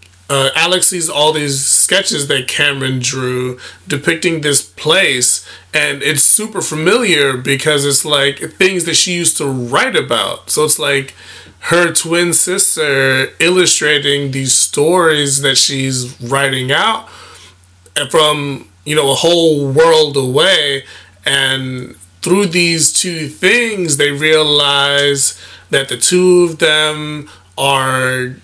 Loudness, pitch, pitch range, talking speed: -12 LUFS, 140 Hz, 130-165 Hz, 125 wpm